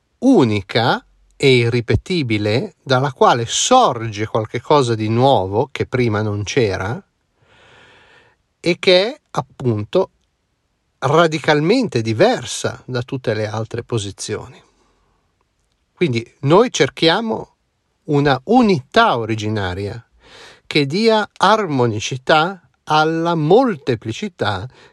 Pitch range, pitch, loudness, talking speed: 115-170 Hz, 130 Hz, -17 LUFS, 85 wpm